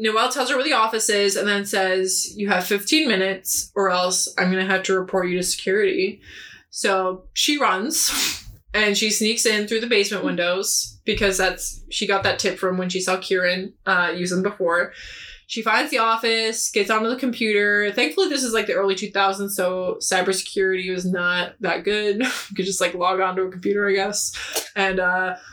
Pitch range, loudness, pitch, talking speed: 185-220 Hz, -21 LUFS, 195 Hz, 200 wpm